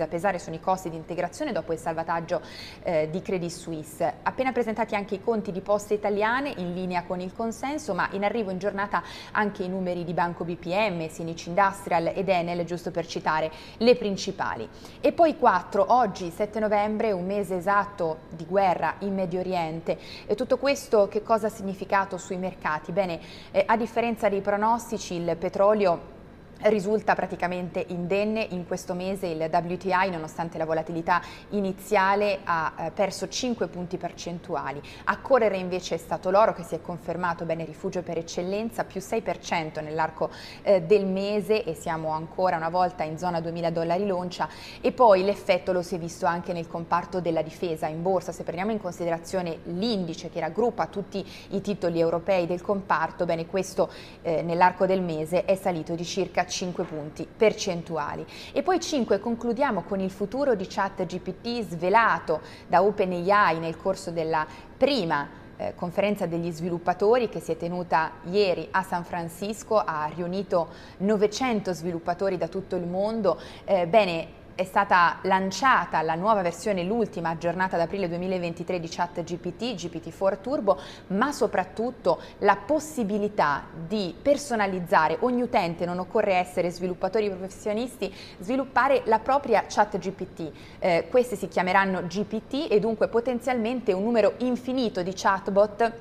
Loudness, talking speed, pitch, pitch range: -26 LUFS, 155 wpm, 185 Hz, 170-210 Hz